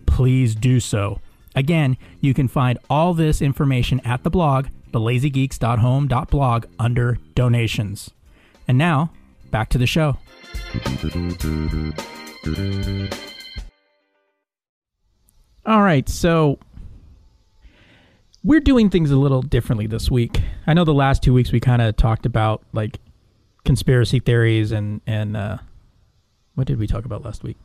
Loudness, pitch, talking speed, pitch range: -19 LUFS, 120 Hz, 125 wpm, 100-135 Hz